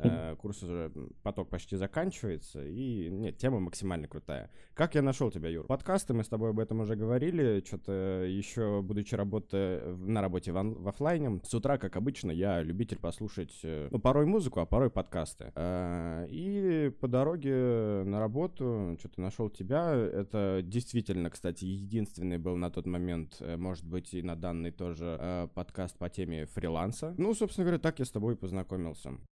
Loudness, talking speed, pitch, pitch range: -34 LUFS, 165 wpm, 100 Hz, 90-120 Hz